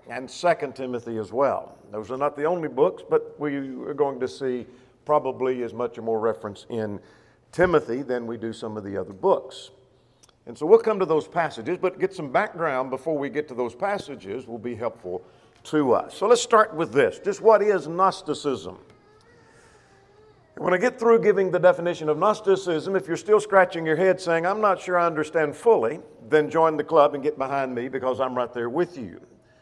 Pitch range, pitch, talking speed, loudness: 125-185 Hz, 150 Hz, 205 wpm, -24 LUFS